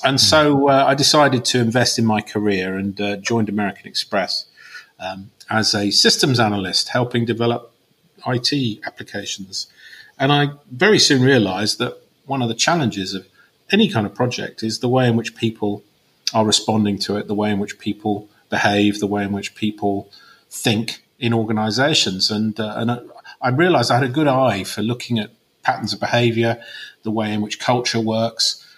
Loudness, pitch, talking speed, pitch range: -18 LUFS, 110 Hz, 175 wpm, 105-125 Hz